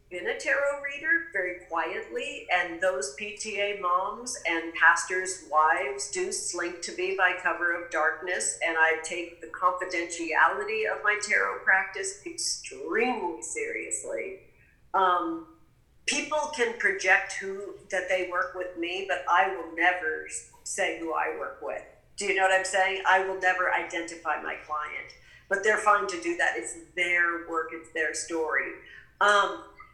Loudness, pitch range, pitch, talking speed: -27 LUFS, 170-275 Hz, 185 Hz, 150 wpm